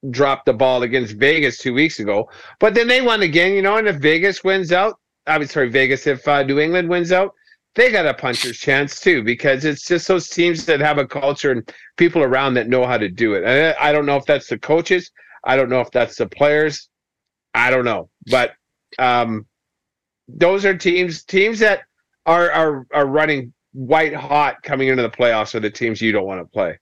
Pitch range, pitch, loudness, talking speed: 130-180 Hz, 150 Hz, -17 LUFS, 215 wpm